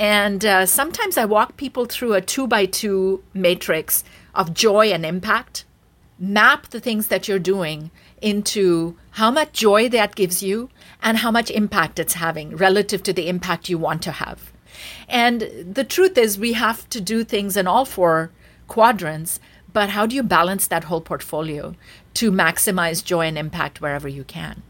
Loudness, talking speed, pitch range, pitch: -19 LUFS, 175 wpm, 170-220 Hz, 195 Hz